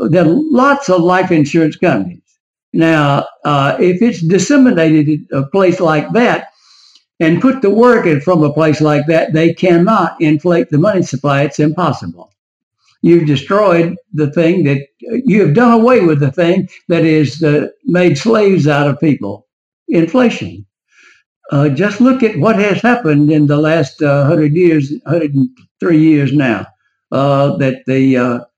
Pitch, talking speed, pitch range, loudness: 160 Hz, 160 wpm, 145-185 Hz, -12 LUFS